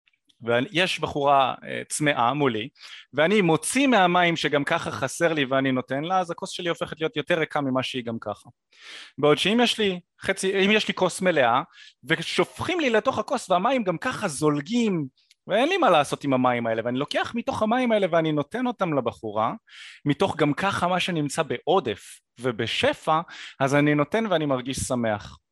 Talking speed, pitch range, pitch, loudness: 160 wpm, 135-190 Hz, 160 Hz, -24 LUFS